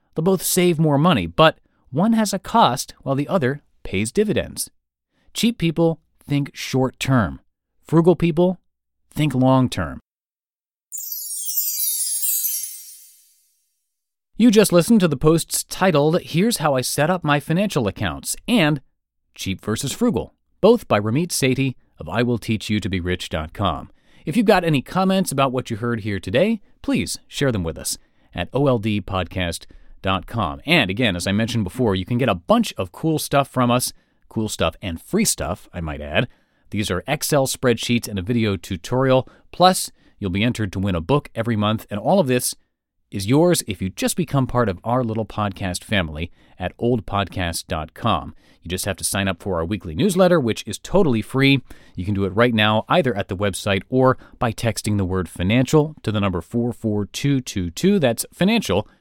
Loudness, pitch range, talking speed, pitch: -20 LUFS, 100-155 Hz, 170 wpm, 120 Hz